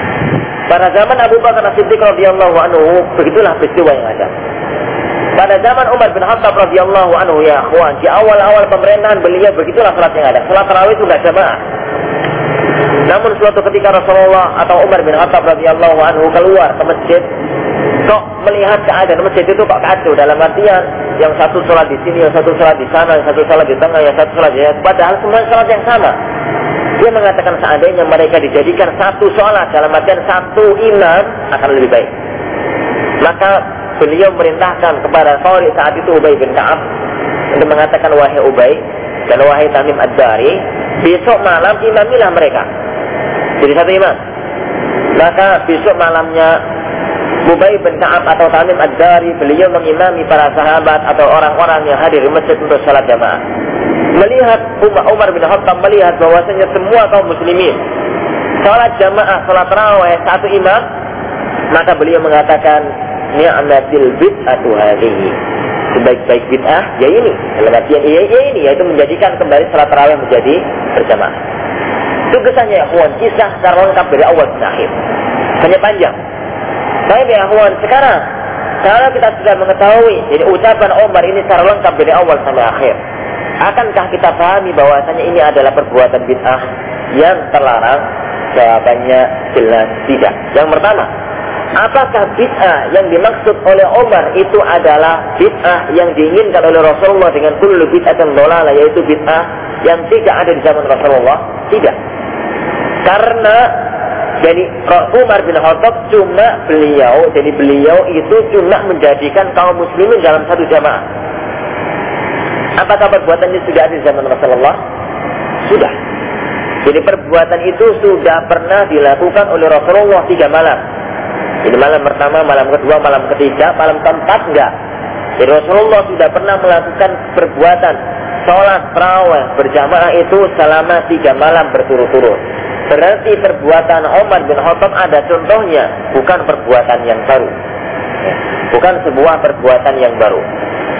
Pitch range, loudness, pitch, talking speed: 155-205 Hz, -8 LUFS, 175 Hz, 135 wpm